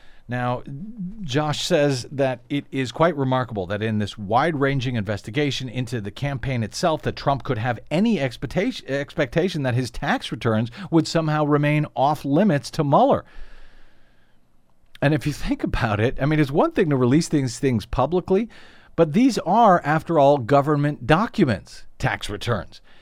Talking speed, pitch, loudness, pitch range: 155 wpm, 140 Hz, -22 LUFS, 120-155 Hz